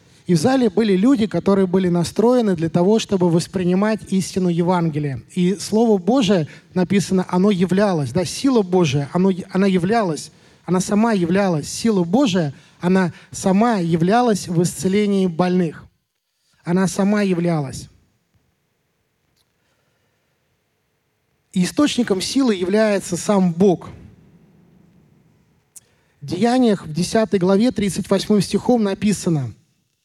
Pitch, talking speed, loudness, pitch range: 185 Hz, 110 wpm, -18 LUFS, 175-210 Hz